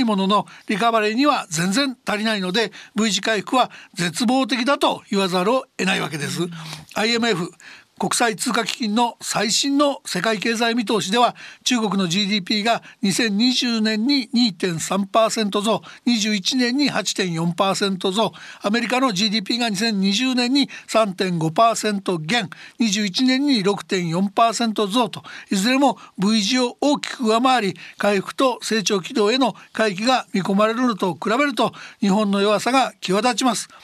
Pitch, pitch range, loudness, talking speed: 220 Hz, 200-245 Hz, -20 LUFS, 245 characters per minute